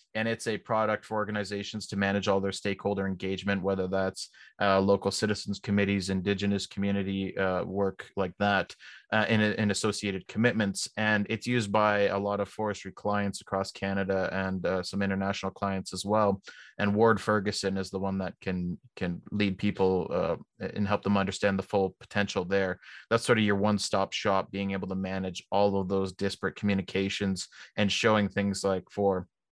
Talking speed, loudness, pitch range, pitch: 175 wpm, -29 LUFS, 95-105 Hz, 100 Hz